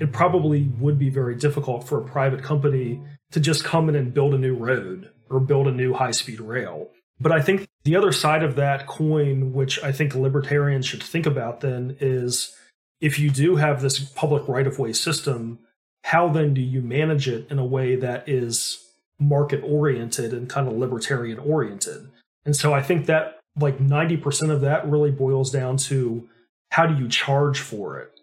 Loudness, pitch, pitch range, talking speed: -22 LUFS, 140 Hz, 130-150 Hz, 195 wpm